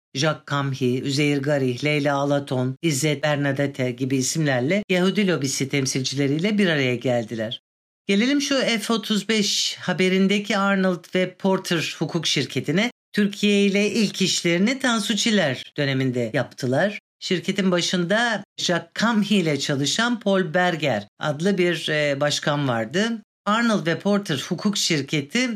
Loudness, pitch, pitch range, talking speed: -22 LUFS, 175 Hz, 140-200 Hz, 115 wpm